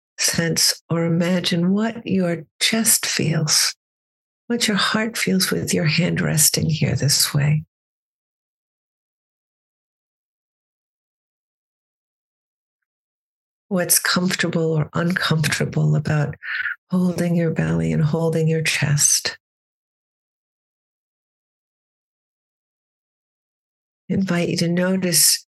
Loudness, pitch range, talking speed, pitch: -19 LUFS, 155-180 Hz, 80 wpm, 170 Hz